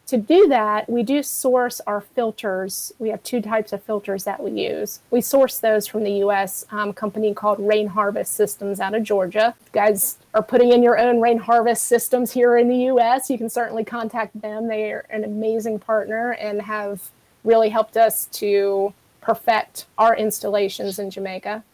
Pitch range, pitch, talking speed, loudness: 205-235 Hz, 220 Hz, 180 wpm, -20 LUFS